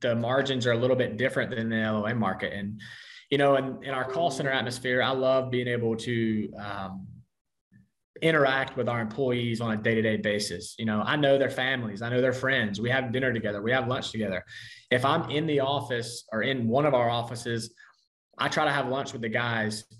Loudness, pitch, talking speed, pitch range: -27 LUFS, 120 Hz, 220 wpm, 110-135 Hz